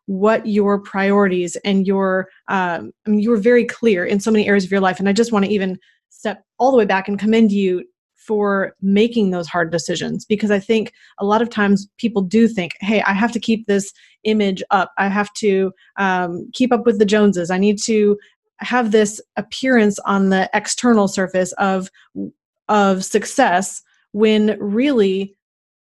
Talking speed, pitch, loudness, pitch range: 185 wpm, 205 Hz, -17 LUFS, 195-220 Hz